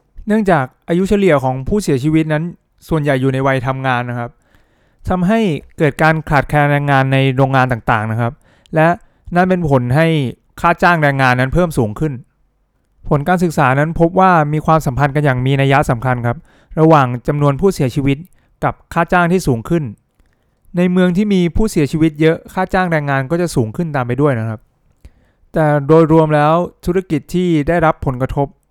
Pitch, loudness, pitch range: 150 Hz, -15 LUFS, 135-170 Hz